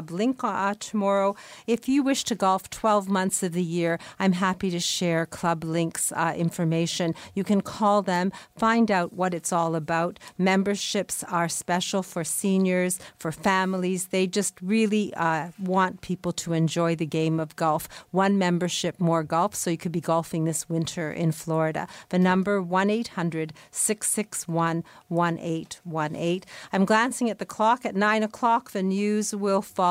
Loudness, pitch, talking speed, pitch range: -25 LUFS, 185 Hz, 165 wpm, 165-200 Hz